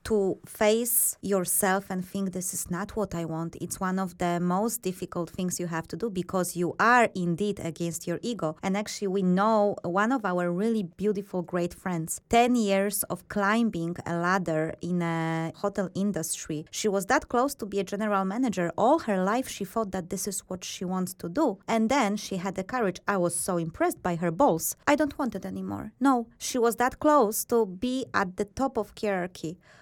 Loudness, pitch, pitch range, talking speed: -27 LUFS, 195 Hz, 175-220 Hz, 205 wpm